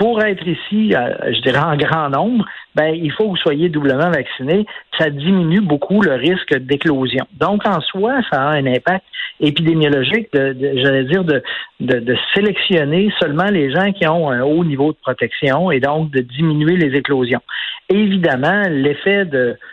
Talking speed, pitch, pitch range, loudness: 175 wpm, 160 Hz, 140-190 Hz, -16 LUFS